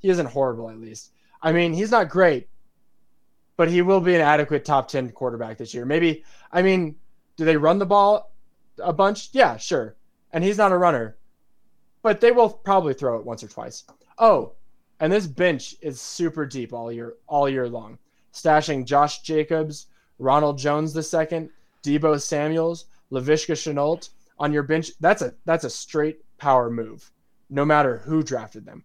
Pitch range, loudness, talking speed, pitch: 135-175 Hz, -22 LUFS, 175 wpm, 155 Hz